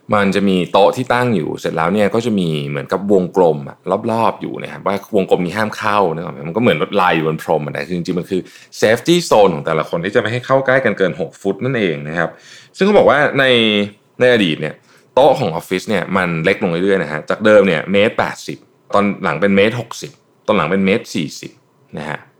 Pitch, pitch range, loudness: 100 Hz, 90-110 Hz, -15 LUFS